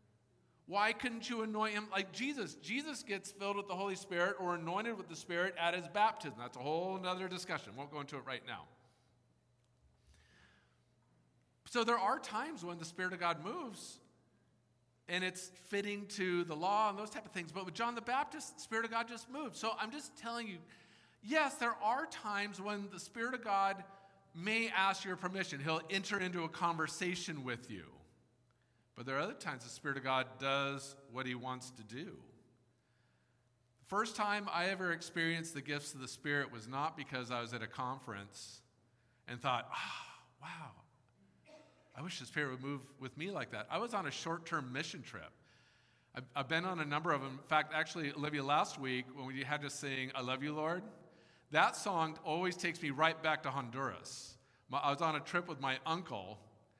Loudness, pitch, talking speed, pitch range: -39 LUFS, 160 Hz, 195 wpm, 130-195 Hz